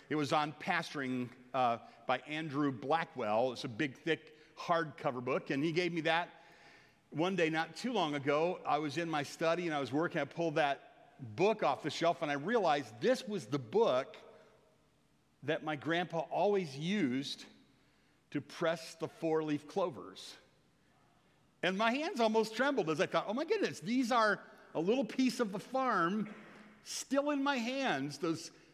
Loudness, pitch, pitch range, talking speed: -35 LUFS, 165 Hz, 150-205 Hz, 170 wpm